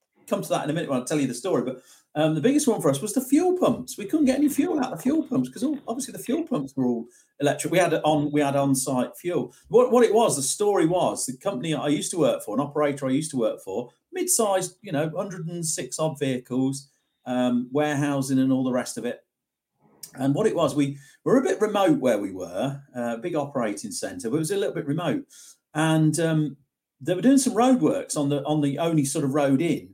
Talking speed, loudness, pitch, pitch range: 250 wpm, -24 LUFS, 155 Hz, 140-220 Hz